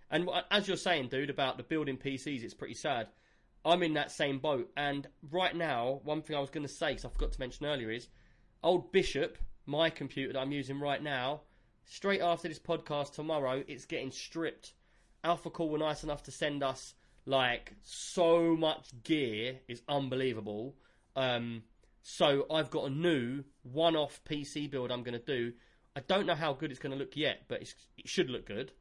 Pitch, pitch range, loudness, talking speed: 145 Hz, 130-160 Hz, -34 LUFS, 200 wpm